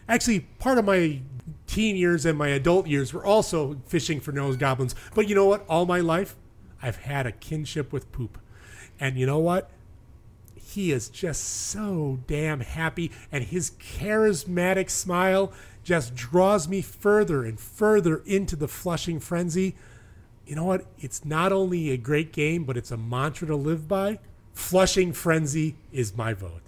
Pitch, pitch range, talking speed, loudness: 155 Hz, 130-185 Hz, 165 wpm, -25 LUFS